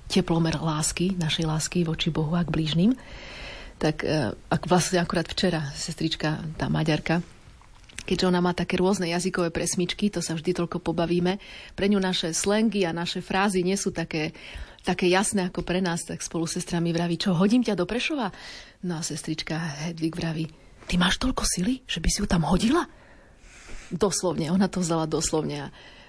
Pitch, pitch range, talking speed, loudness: 175 Hz, 165-185 Hz, 170 wpm, -26 LUFS